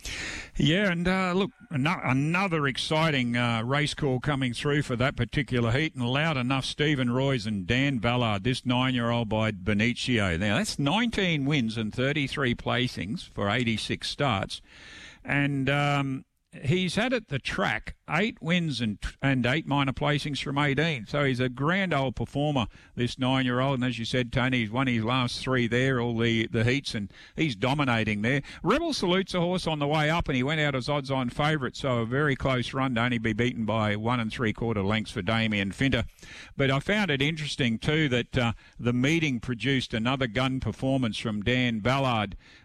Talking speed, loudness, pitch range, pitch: 185 wpm, -27 LUFS, 120-145 Hz, 130 Hz